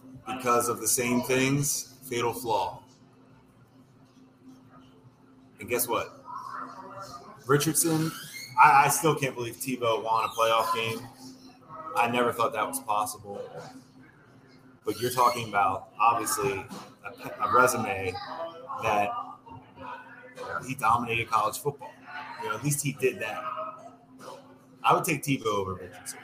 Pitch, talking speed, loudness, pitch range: 130 Hz, 125 wpm, -27 LUFS, 115-135 Hz